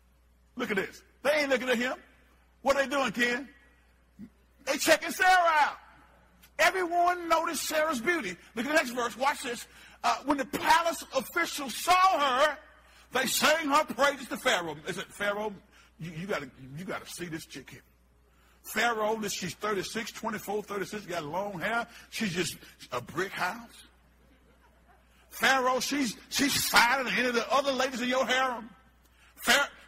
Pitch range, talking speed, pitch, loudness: 190-290 Hz, 160 wpm, 245 Hz, -28 LUFS